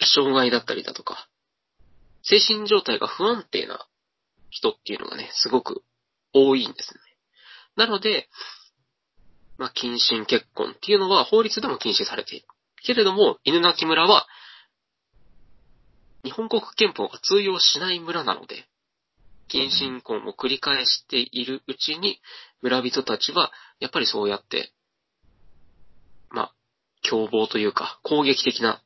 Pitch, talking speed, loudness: 145 Hz, 260 characters per minute, -22 LUFS